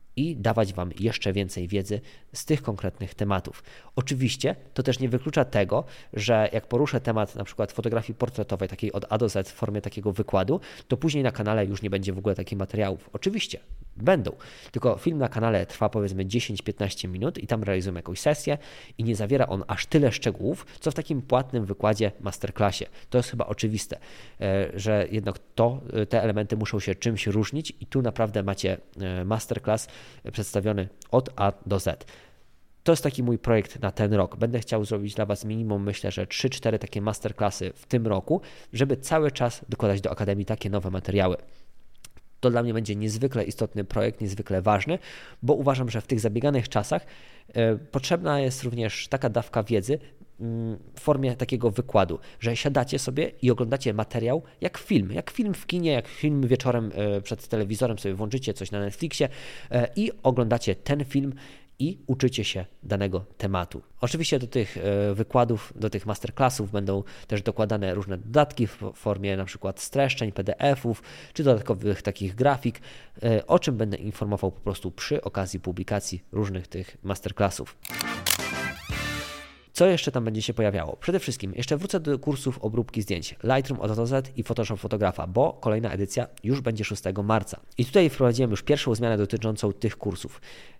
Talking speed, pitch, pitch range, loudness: 165 wpm, 110 Hz, 100-125 Hz, -27 LUFS